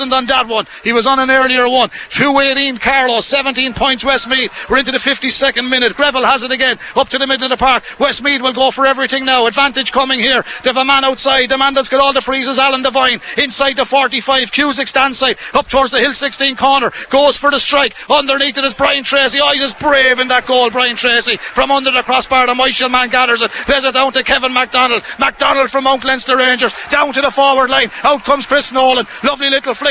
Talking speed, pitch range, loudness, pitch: 225 wpm, 255-275 Hz, -11 LUFS, 265 Hz